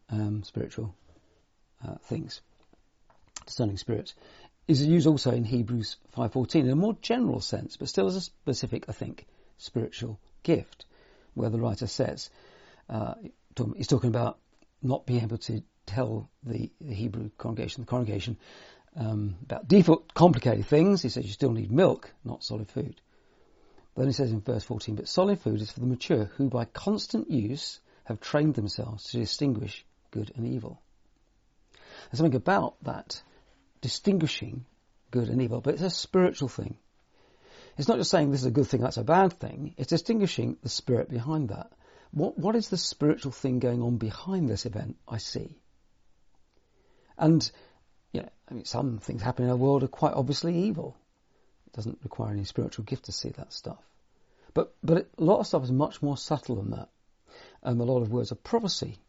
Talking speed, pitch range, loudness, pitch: 180 wpm, 110-150 Hz, -28 LUFS, 125 Hz